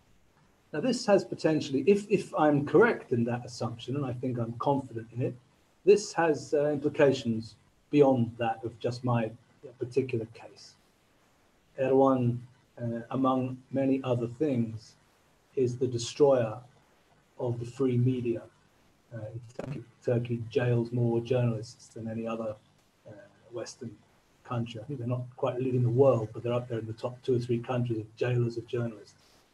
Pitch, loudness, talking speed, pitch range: 125 Hz, -29 LUFS, 155 wpm, 115-135 Hz